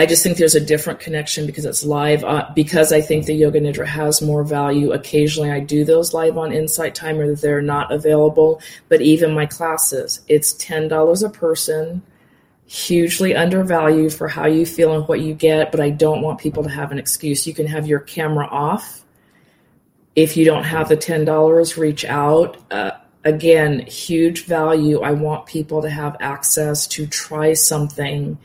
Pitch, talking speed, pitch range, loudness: 155 Hz, 180 wpm, 150-160 Hz, -17 LUFS